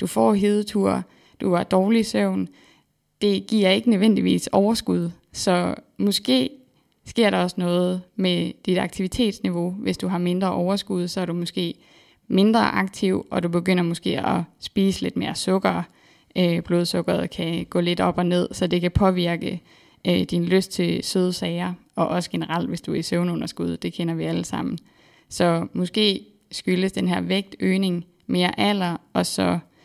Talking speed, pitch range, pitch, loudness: 160 wpm, 170-195 Hz, 180 Hz, -23 LUFS